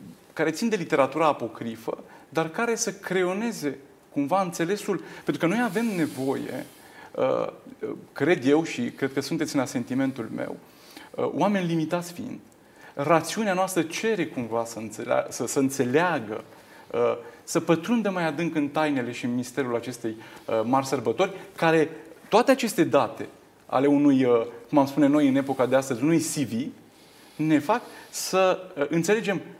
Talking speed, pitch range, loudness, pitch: 140 wpm, 140-200 Hz, -25 LUFS, 160 Hz